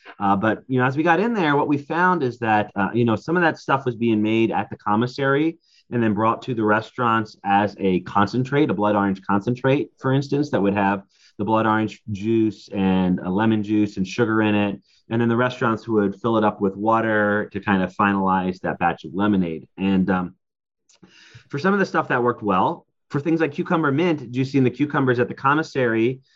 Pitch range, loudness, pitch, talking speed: 100-135 Hz, -21 LUFS, 115 Hz, 220 wpm